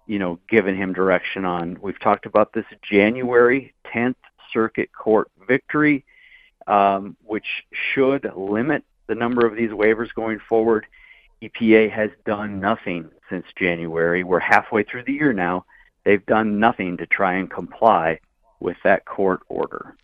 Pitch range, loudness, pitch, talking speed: 95-120 Hz, -20 LUFS, 110 Hz, 145 wpm